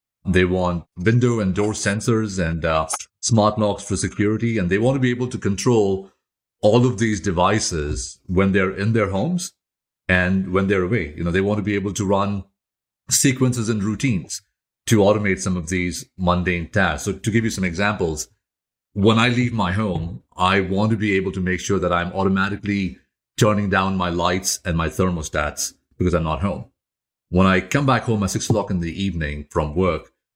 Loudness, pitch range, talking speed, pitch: -20 LUFS, 90-105 Hz, 195 wpm, 95 Hz